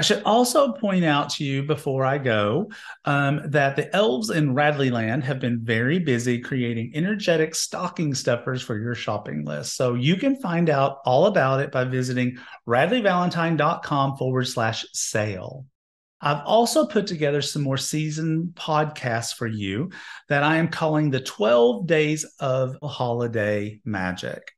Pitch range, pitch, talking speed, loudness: 120-160 Hz, 140 Hz, 150 wpm, -23 LUFS